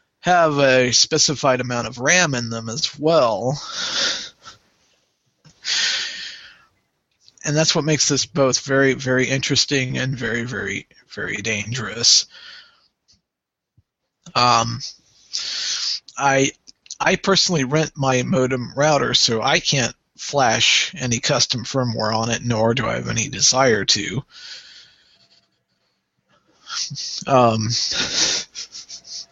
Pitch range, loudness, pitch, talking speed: 115-140 Hz, -18 LUFS, 130 Hz, 100 wpm